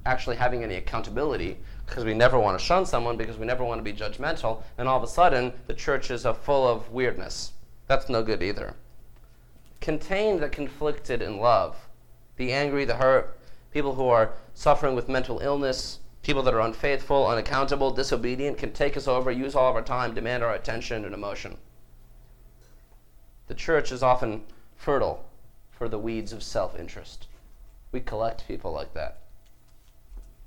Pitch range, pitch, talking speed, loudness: 110-135 Hz, 120 Hz, 165 wpm, -27 LUFS